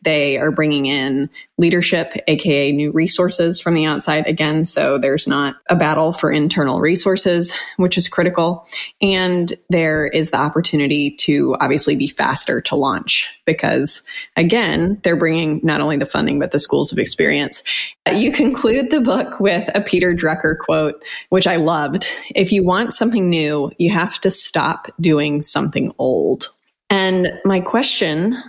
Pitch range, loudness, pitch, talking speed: 155-190 Hz, -16 LUFS, 170 Hz, 155 wpm